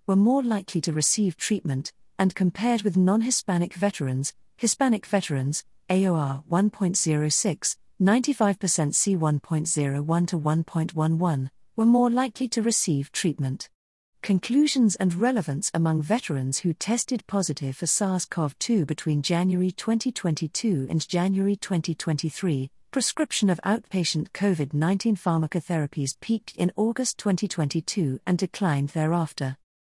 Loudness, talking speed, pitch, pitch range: -25 LUFS, 115 wpm, 180 Hz, 155-205 Hz